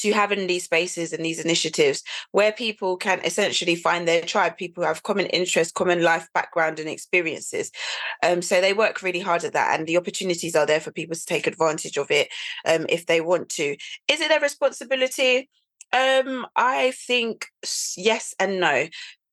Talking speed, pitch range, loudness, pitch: 185 wpm, 170-260 Hz, -23 LUFS, 185 Hz